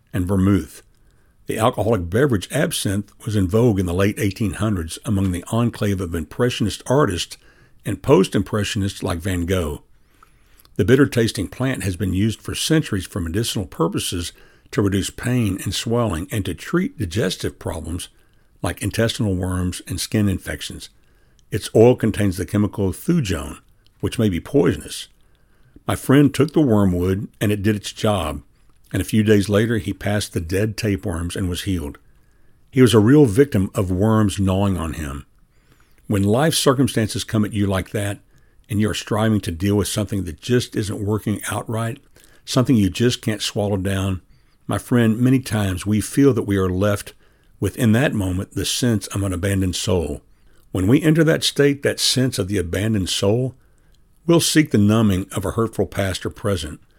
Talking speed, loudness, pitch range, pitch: 170 wpm, -20 LUFS, 95-115 Hz, 105 Hz